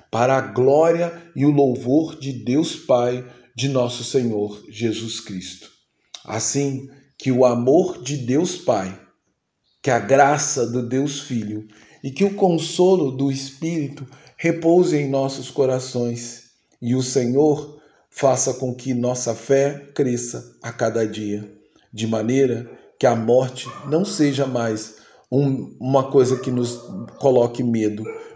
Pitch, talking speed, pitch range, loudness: 130 Hz, 135 wpm, 120-140 Hz, -20 LUFS